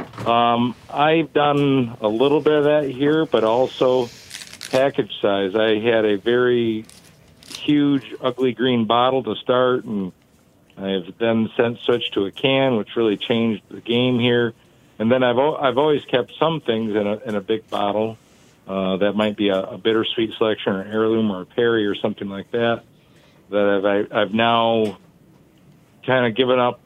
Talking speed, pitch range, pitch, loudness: 170 wpm, 105-130 Hz, 115 Hz, -20 LUFS